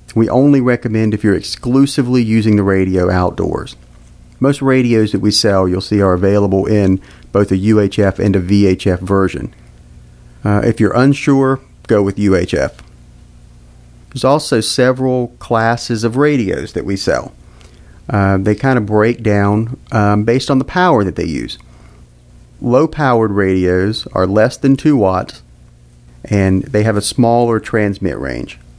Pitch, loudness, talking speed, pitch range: 105 Hz, -14 LUFS, 150 wpm, 95-120 Hz